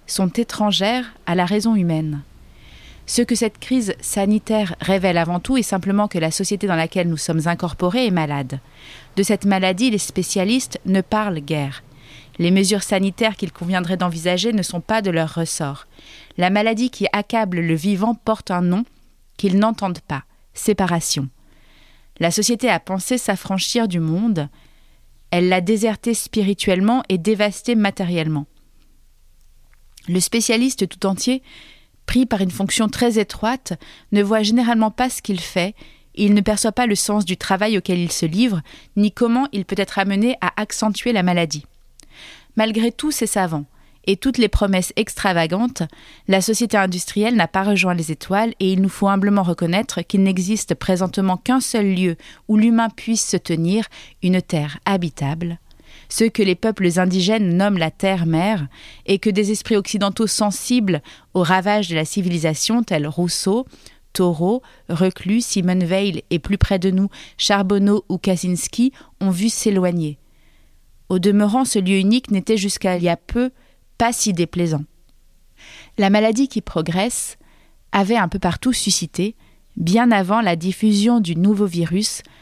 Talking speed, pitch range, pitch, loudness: 160 wpm, 175-220 Hz, 195 Hz, -19 LUFS